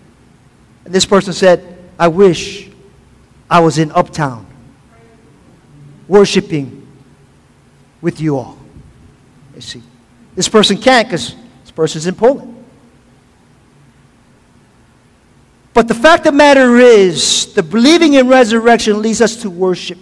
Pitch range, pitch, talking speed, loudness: 145-220 Hz, 180 Hz, 120 wpm, -10 LUFS